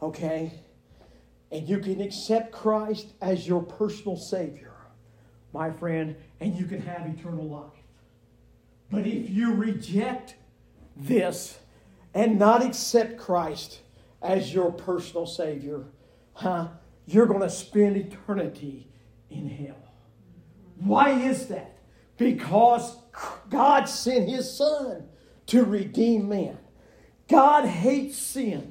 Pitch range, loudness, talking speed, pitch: 155-230 Hz, -25 LUFS, 110 wpm, 190 Hz